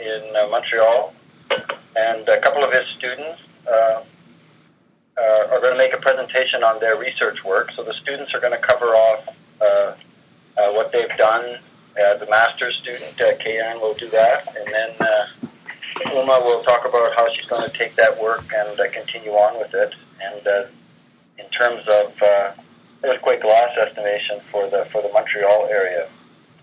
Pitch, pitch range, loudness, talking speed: 110 Hz, 105-125 Hz, -18 LUFS, 175 wpm